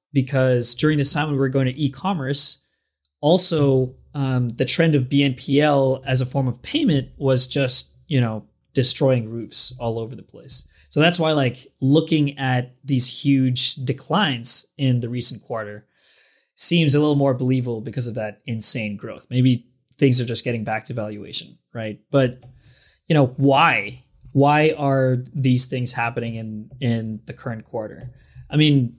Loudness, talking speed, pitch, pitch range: -19 LUFS, 165 wpm, 130 Hz, 120-140 Hz